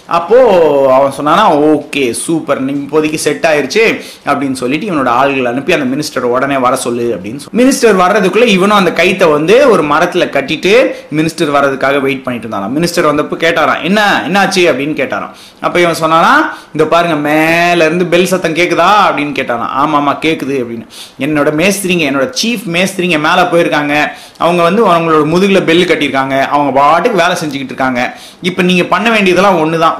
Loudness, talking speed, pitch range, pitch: -10 LUFS, 160 wpm, 140-180 Hz, 160 Hz